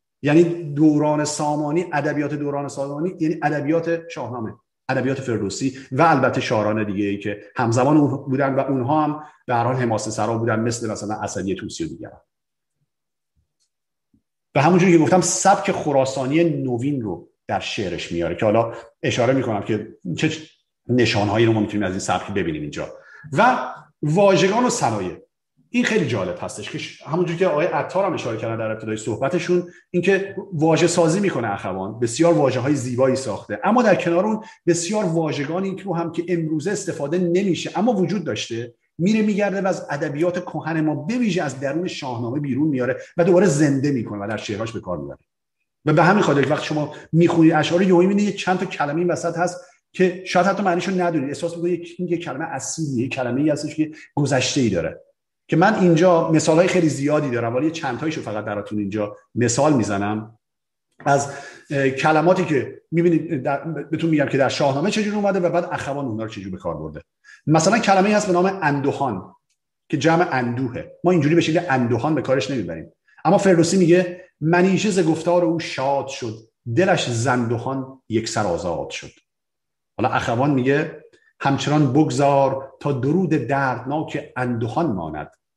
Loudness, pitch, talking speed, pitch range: -20 LUFS, 150 Hz, 165 wpm, 130-175 Hz